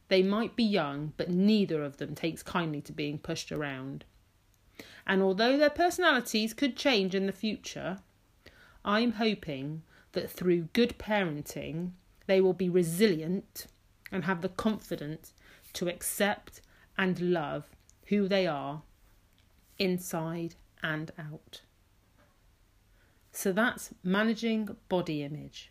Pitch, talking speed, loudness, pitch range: 175 Hz, 120 wpm, -31 LUFS, 145-205 Hz